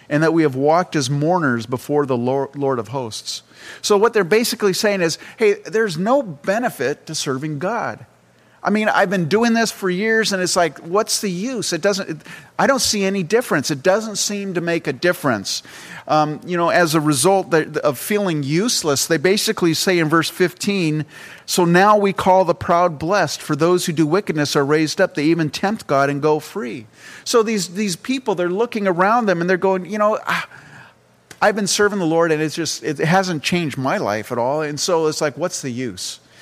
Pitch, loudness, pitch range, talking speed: 175 Hz, -18 LUFS, 155-200 Hz, 210 wpm